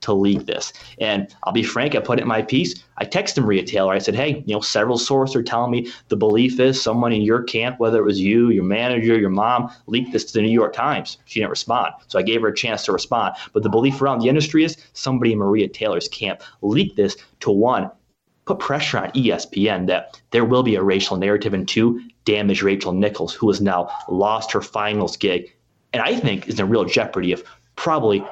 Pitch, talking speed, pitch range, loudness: 115 Hz, 230 wpm, 100-120 Hz, -20 LUFS